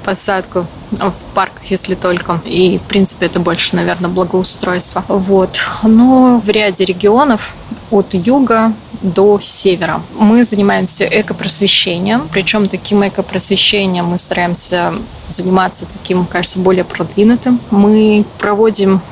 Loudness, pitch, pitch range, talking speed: -11 LUFS, 195 Hz, 185-210 Hz, 115 wpm